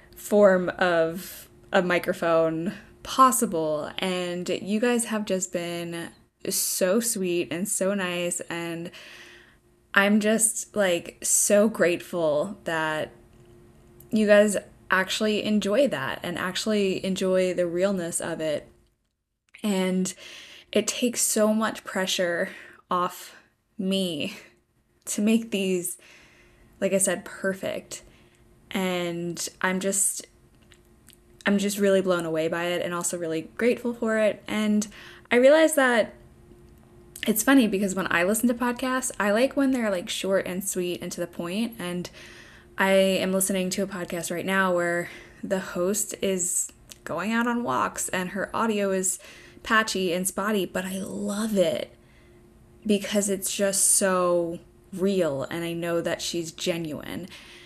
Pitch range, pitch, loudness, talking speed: 175-210 Hz, 190 Hz, -25 LUFS, 135 wpm